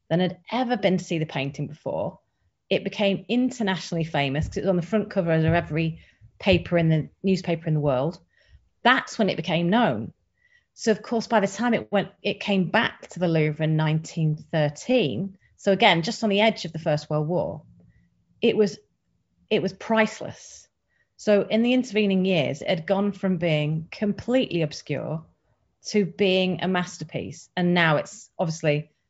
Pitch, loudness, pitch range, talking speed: 185 Hz, -24 LUFS, 160-205 Hz, 175 wpm